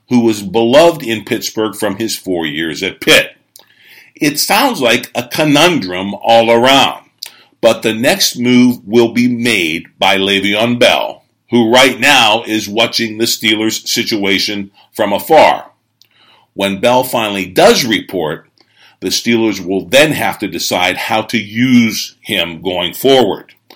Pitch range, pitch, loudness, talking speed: 100-120 Hz, 115 Hz, -12 LUFS, 140 wpm